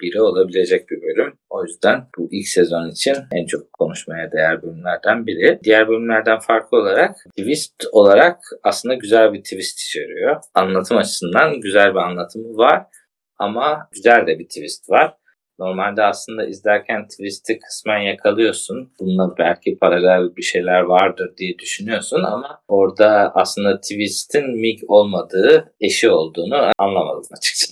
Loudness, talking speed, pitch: -17 LUFS, 135 wpm, 110 Hz